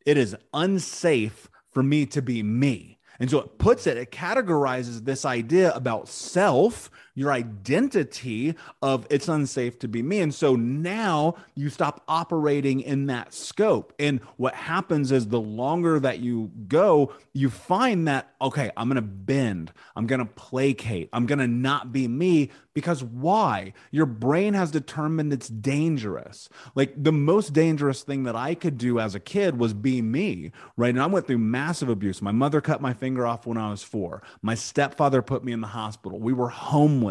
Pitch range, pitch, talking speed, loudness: 120-150 Hz, 135 Hz, 185 wpm, -25 LUFS